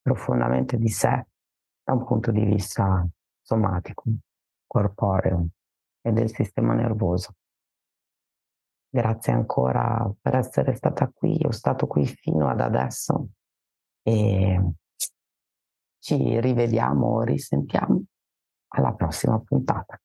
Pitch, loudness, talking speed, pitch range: 95 Hz, -24 LUFS, 100 wpm, 70-115 Hz